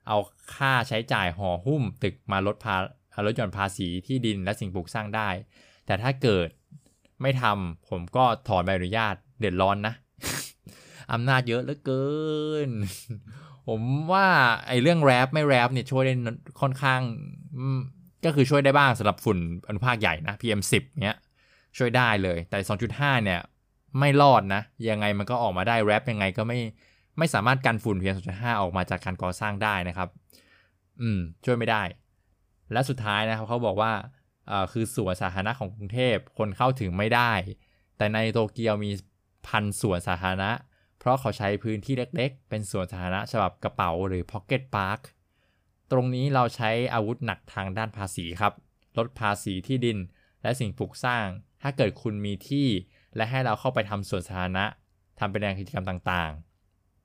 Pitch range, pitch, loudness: 95-125 Hz, 110 Hz, -26 LUFS